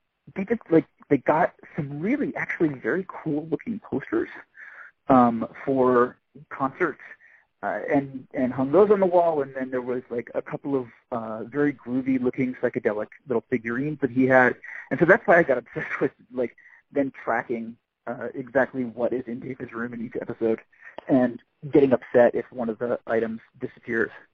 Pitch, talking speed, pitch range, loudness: 130 Hz, 175 wpm, 120-145 Hz, -25 LUFS